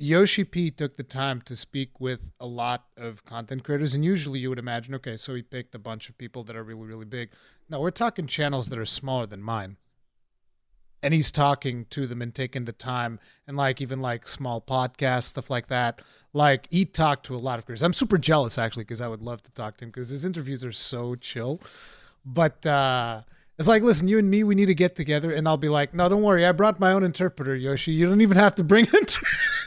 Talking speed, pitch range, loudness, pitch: 235 wpm, 120-160 Hz, -24 LUFS, 135 Hz